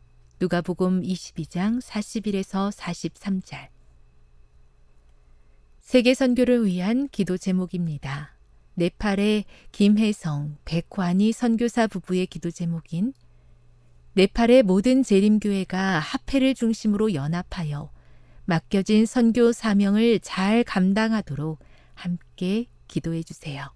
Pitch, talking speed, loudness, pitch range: 185 Hz, 215 characters per minute, -23 LUFS, 150-215 Hz